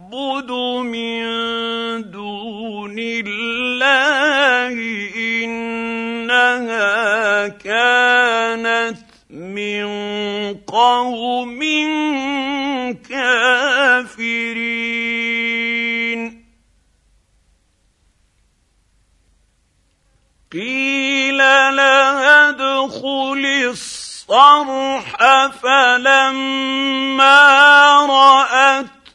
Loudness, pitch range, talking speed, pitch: -14 LUFS, 225-270 Hz, 30 wpm, 240 Hz